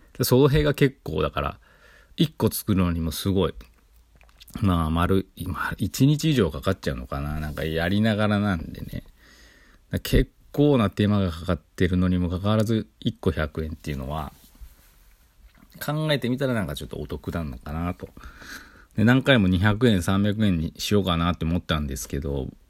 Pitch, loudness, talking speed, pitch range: 90 Hz, -24 LUFS, 310 characters per minute, 80-110 Hz